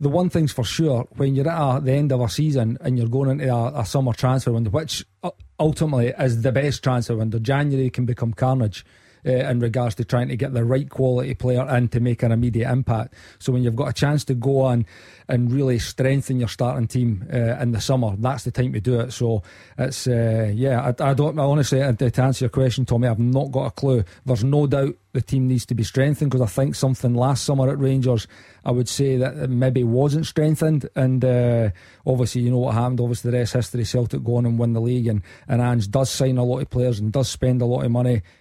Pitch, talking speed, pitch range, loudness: 125 Hz, 240 wpm, 120-135 Hz, -21 LUFS